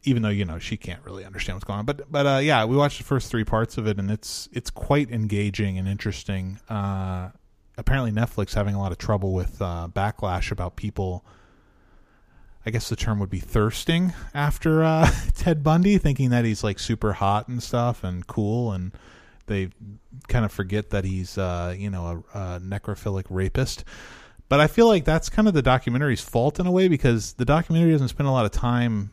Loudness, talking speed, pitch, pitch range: -24 LUFS, 205 wpm, 105 Hz, 100-130 Hz